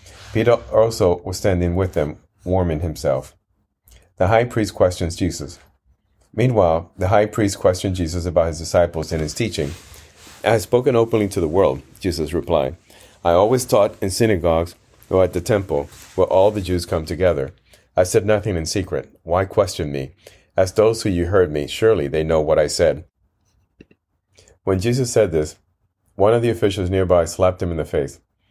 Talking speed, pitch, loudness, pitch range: 175 wpm, 95 Hz, -19 LUFS, 85-105 Hz